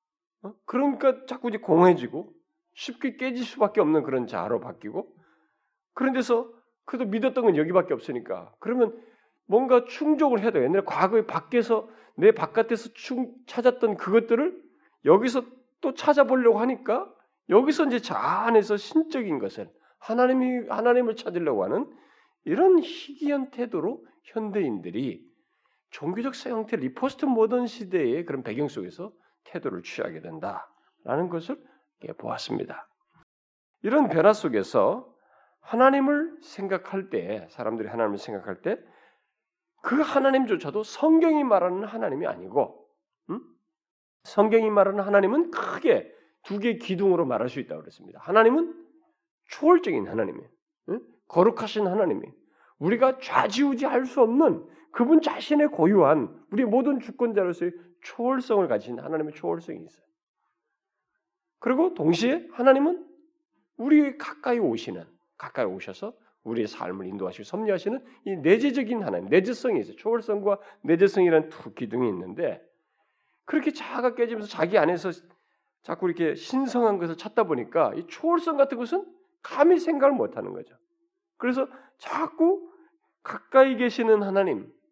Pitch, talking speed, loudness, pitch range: 250 Hz, 315 characters per minute, -25 LUFS, 210-300 Hz